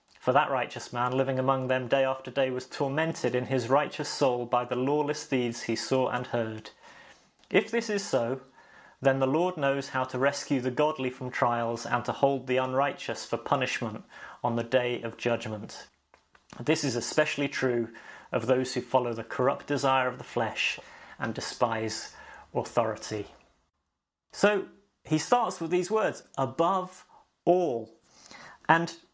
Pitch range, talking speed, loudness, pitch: 120-145 Hz, 160 wpm, -29 LUFS, 130 Hz